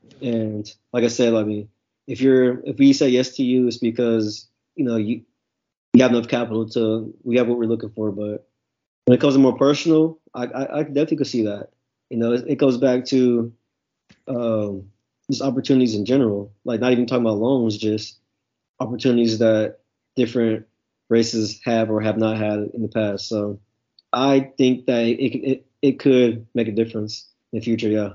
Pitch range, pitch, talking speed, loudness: 110-130 Hz, 115 Hz, 190 wpm, -20 LUFS